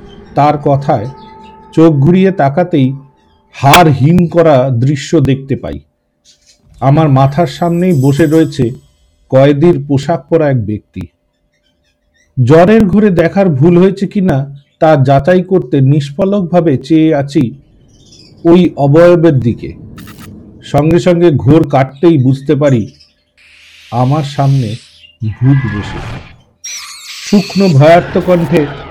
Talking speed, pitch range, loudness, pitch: 100 wpm, 125-170 Hz, -9 LUFS, 145 Hz